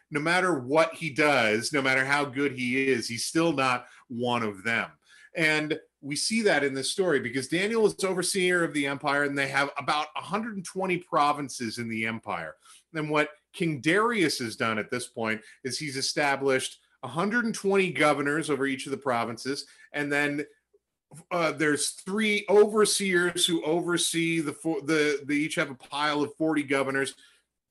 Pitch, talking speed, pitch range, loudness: 150 Hz, 170 wpm, 135-170 Hz, -27 LUFS